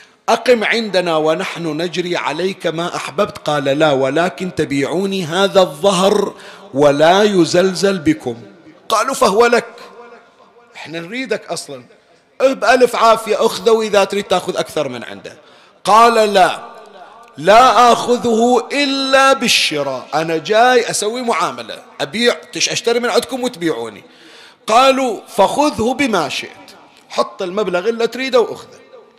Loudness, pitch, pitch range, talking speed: -14 LUFS, 200 Hz, 170-240 Hz, 115 wpm